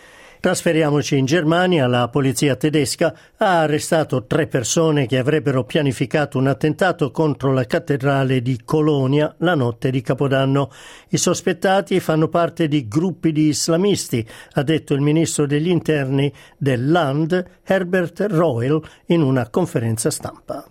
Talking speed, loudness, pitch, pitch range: 130 wpm, -19 LUFS, 155 Hz, 135-165 Hz